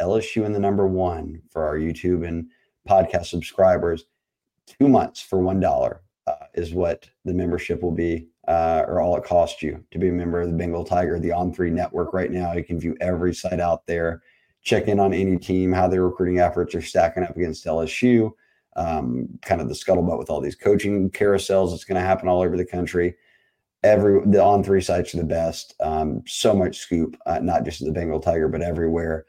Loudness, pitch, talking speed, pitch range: -22 LUFS, 90 Hz, 210 wpm, 85-95 Hz